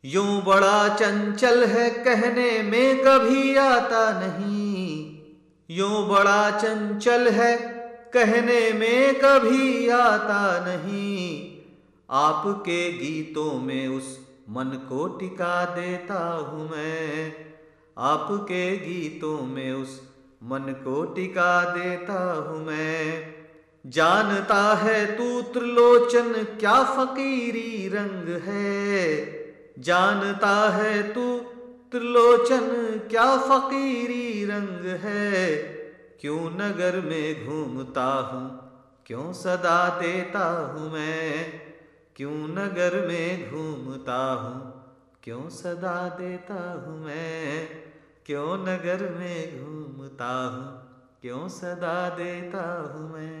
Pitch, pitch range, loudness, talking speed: 180 Hz, 155-220 Hz, -23 LUFS, 95 wpm